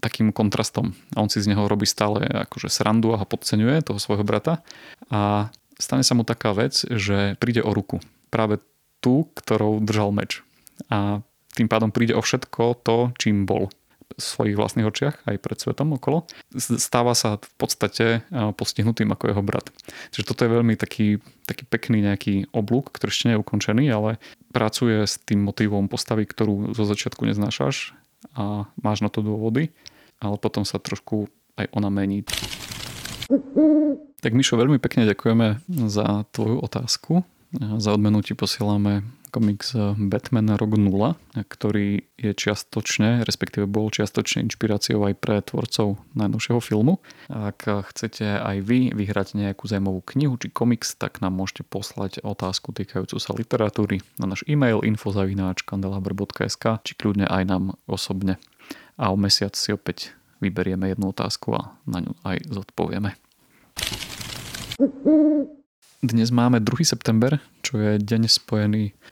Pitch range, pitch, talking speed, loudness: 100-120 Hz, 105 Hz, 145 wpm, -23 LUFS